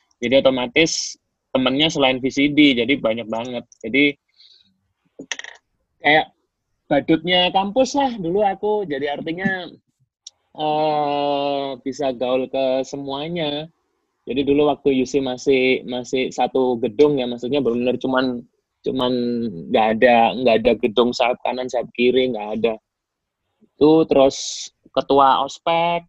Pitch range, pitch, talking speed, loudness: 125-150 Hz, 135 Hz, 120 wpm, -19 LUFS